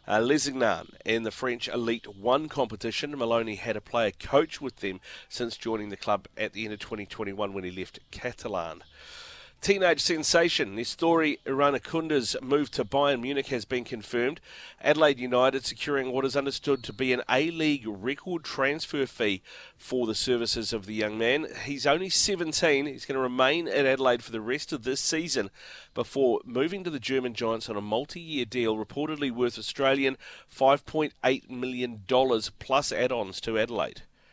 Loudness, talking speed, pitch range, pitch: -28 LUFS, 165 wpm, 115-145 Hz, 130 Hz